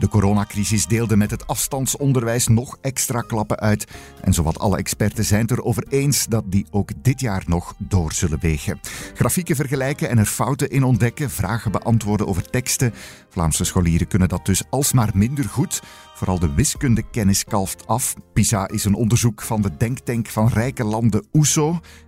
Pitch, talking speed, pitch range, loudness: 110 Hz, 170 wpm, 100-125 Hz, -20 LUFS